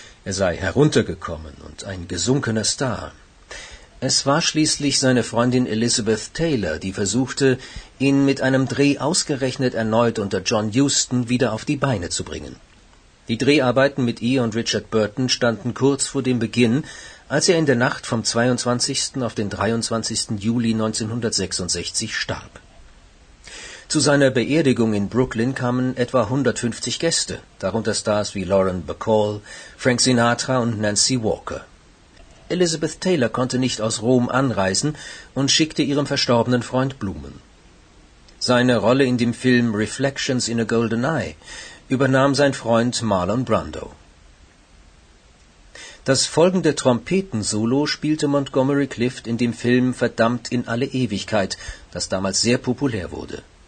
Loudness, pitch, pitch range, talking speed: -20 LUFS, 120 Hz, 110-135 Hz, 135 wpm